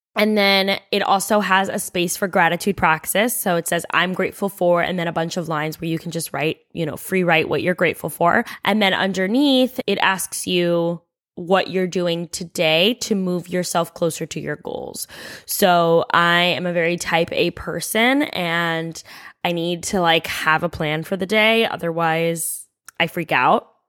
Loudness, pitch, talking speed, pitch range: -19 LUFS, 175 Hz, 190 wpm, 165-195 Hz